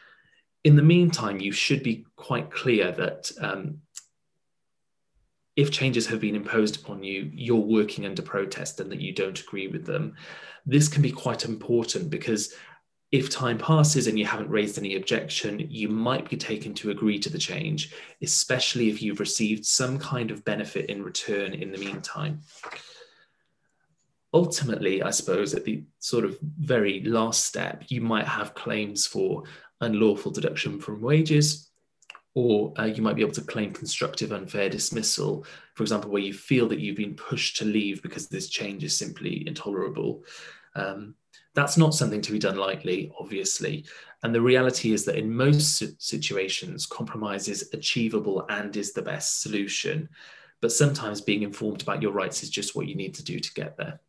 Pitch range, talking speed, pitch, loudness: 105-150 Hz, 170 wpm, 115 Hz, -26 LUFS